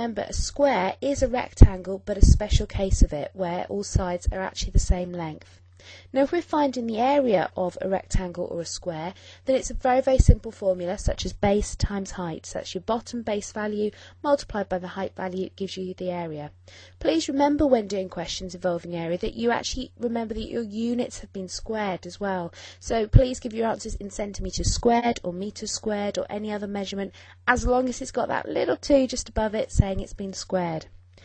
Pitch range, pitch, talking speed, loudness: 180-235 Hz, 200 Hz, 210 wpm, -26 LUFS